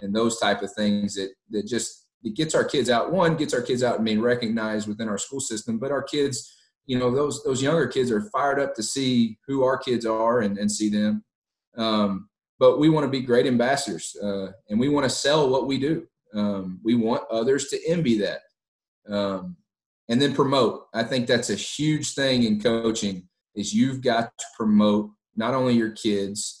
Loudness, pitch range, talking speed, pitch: -24 LUFS, 105-130 Hz, 210 wpm, 115 Hz